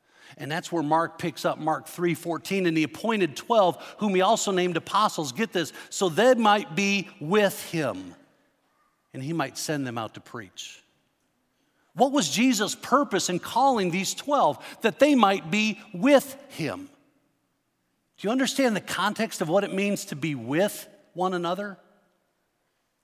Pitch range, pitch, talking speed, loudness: 170-235 Hz, 195 Hz, 160 wpm, -25 LUFS